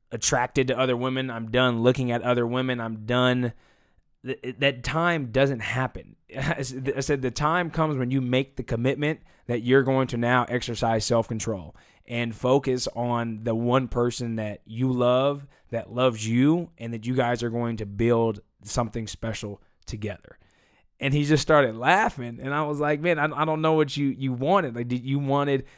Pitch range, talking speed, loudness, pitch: 120-140 Hz, 180 wpm, -25 LUFS, 125 Hz